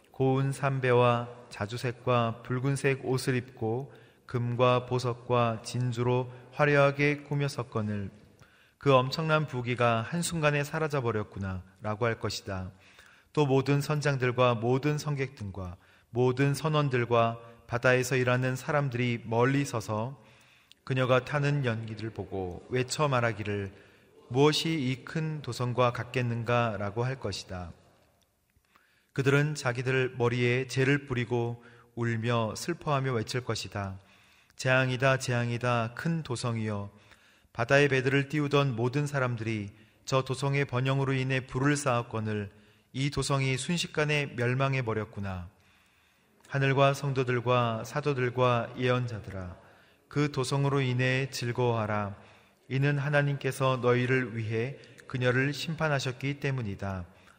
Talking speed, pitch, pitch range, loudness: 275 characters per minute, 125 Hz, 115-135 Hz, -29 LUFS